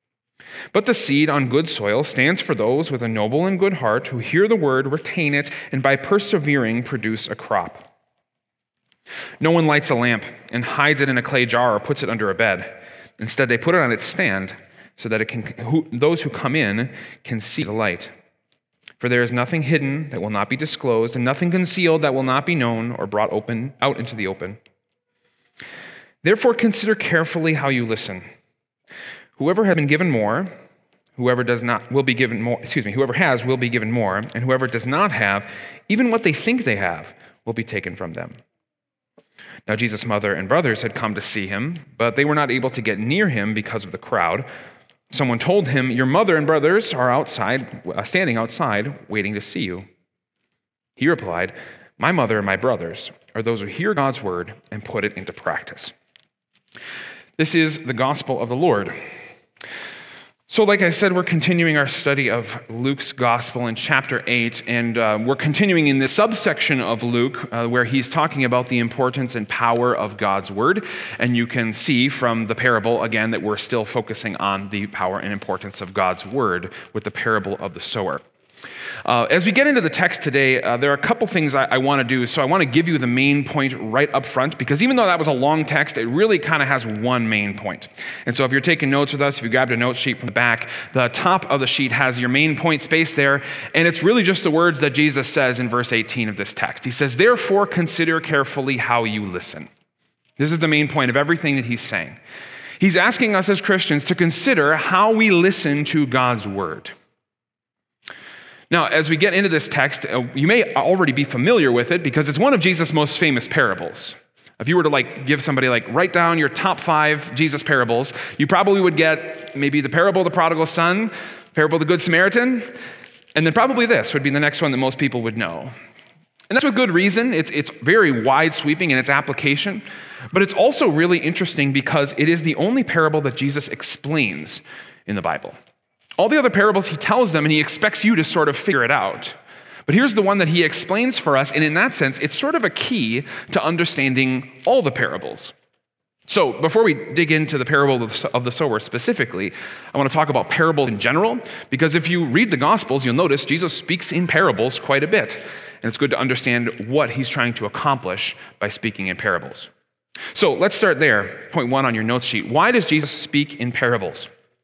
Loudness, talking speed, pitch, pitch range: -19 LUFS, 210 wpm, 140 Hz, 120-165 Hz